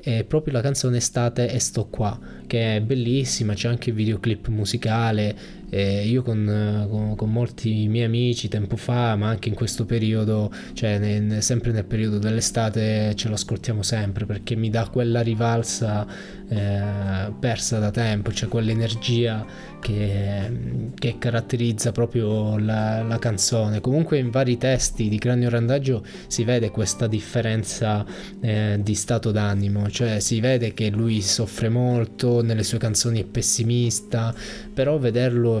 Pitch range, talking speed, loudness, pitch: 105-120 Hz, 150 wpm, -23 LUFS, 115 Hz